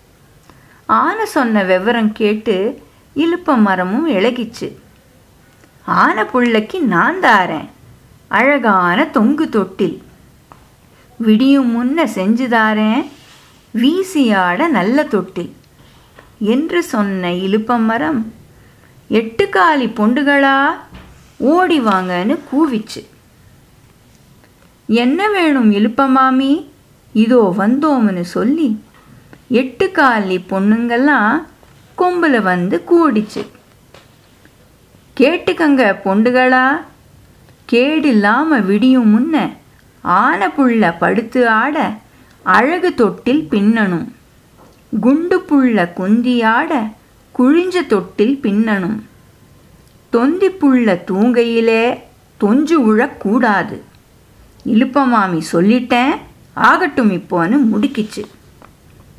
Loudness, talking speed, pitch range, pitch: -14 LUFS, 70 wpm, 215-285 Hz, 240 Hz